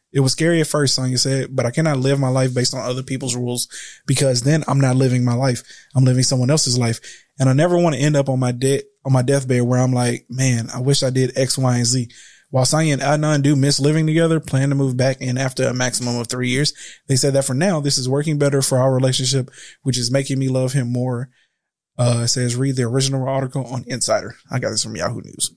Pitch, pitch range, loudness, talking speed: 130 Hz, 125-140 Hz, -18 LUFS, 255 wpm